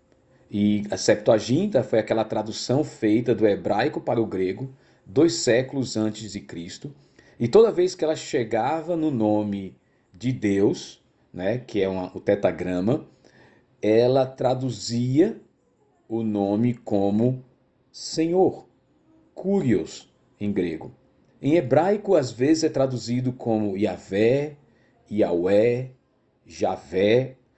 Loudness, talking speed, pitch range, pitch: -23 LUFS, 115 wpm, 105-130 Hz, 120 Hz